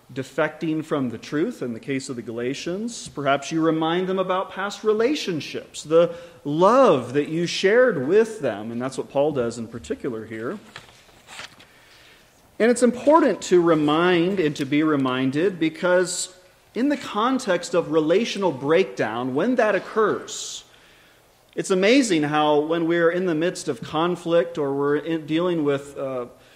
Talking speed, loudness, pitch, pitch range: 150 wpm, -22 LUFS, 165 Hz, 140-185 Hz